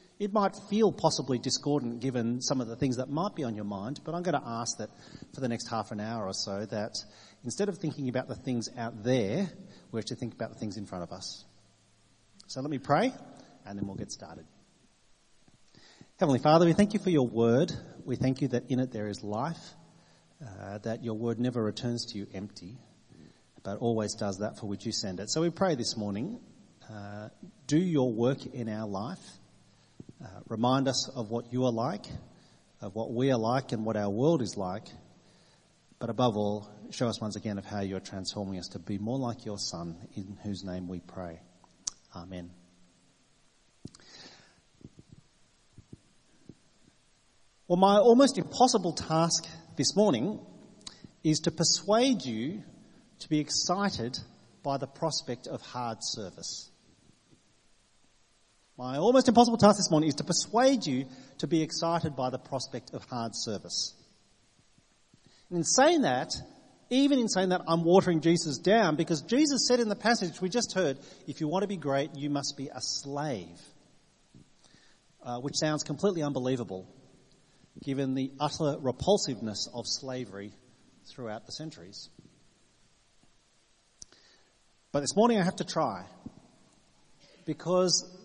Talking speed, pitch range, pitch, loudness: 165 wpm, 110-165 Hz, 130 Hz, -30 LUFS